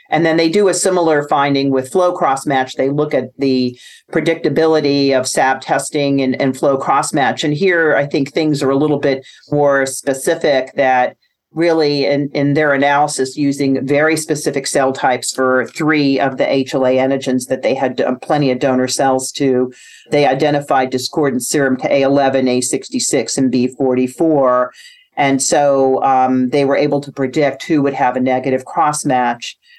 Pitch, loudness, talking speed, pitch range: 140 Hz, -15 LUFS, 170 wpm, 130-150 Hz